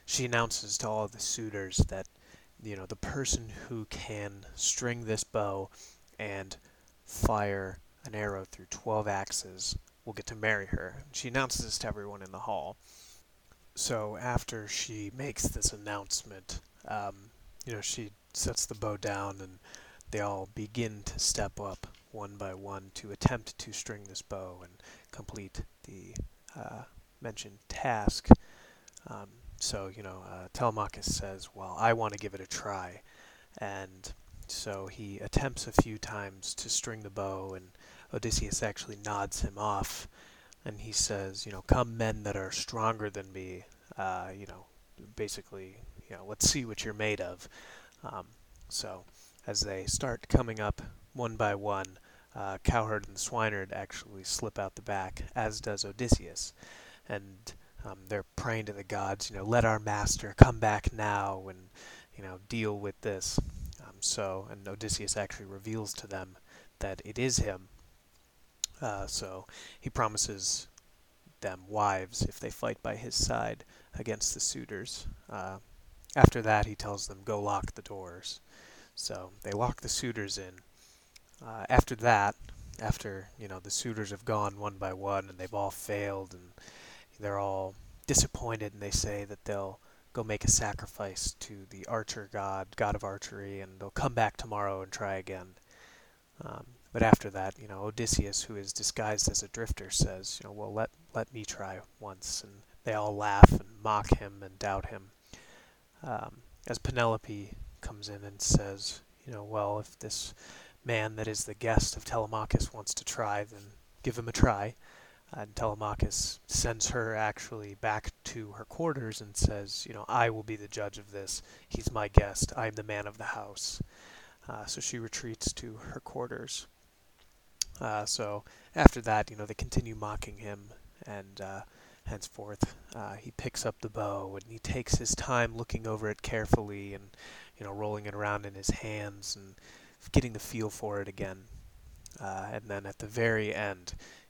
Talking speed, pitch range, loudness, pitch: 170 wpm, 95-110 Hz, -33 LUFS, 105 Hz